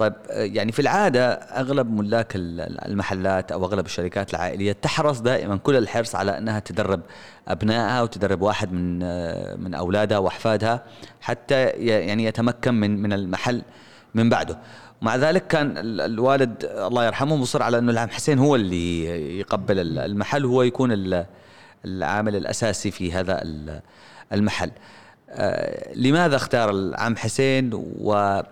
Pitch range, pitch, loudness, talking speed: 95-120 Hz, 105 Hz, -23 LUFS, 125 wpm